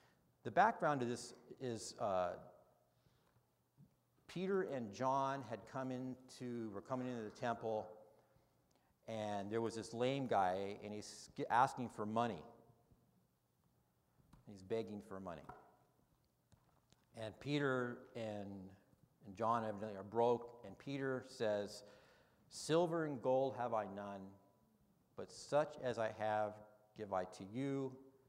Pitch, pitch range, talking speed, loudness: 115 Hz, 105-130 Hz, 125 wpm, -42 LUFS